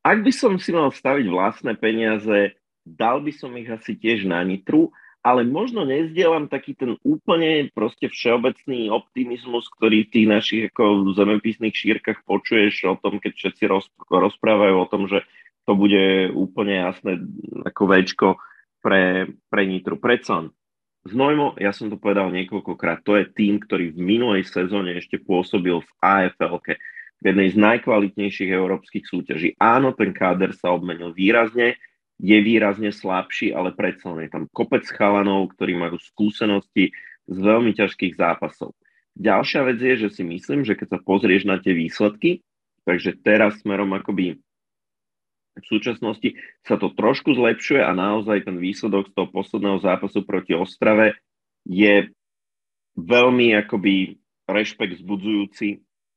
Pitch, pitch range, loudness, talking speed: 105 Hz, 95-110 Hz, -20 LUFS, 145 wpm